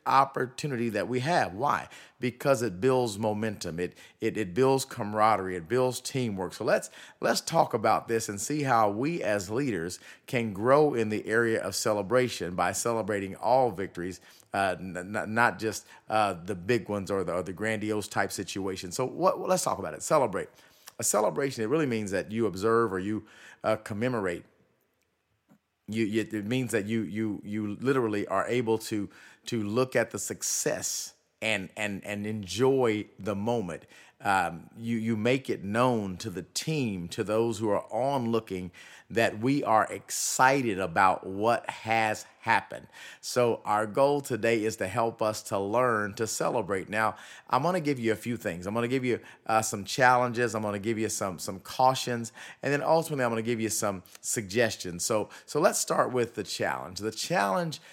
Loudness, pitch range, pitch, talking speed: -29 LUFS, 105-125 Hz, 110 Hz, 180 wpm